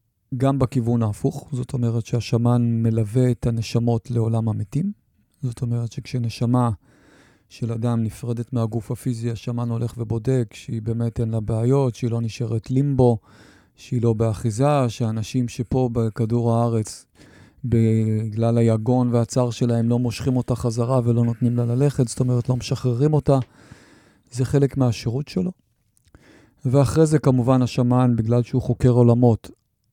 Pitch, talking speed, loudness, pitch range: 120 Hz, 135 wpm, -22 LUFS, 115-130 Hz